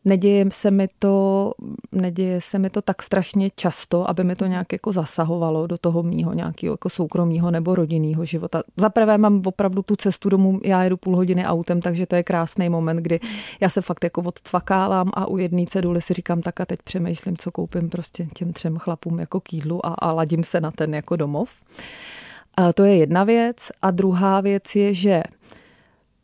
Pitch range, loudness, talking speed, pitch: 170-195 Hz, -21 LUFS, 190 wpm, 180 Hz